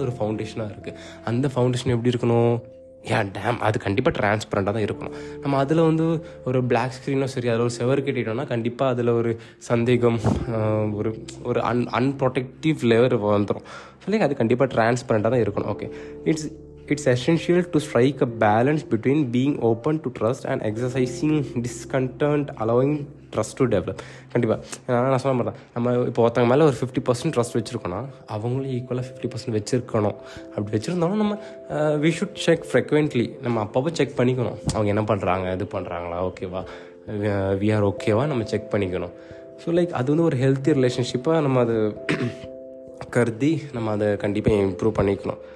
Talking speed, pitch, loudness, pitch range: 155 wpm, 120 Hz, -23 LUFS, 110-135 Hz